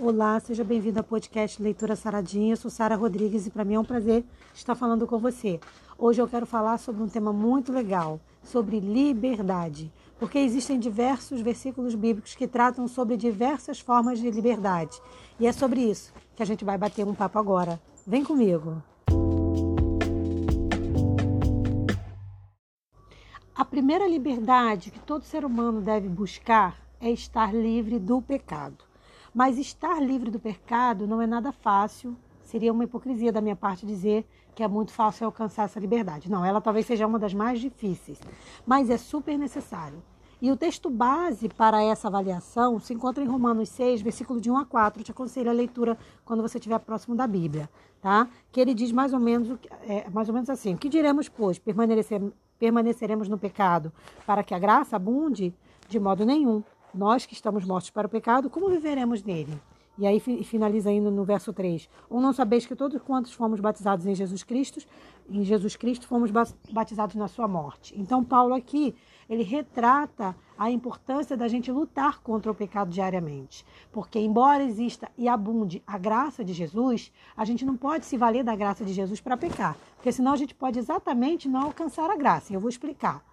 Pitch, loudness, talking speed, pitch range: 230 Hz, -26 LUFS, 180 wpm, 205-250 Hz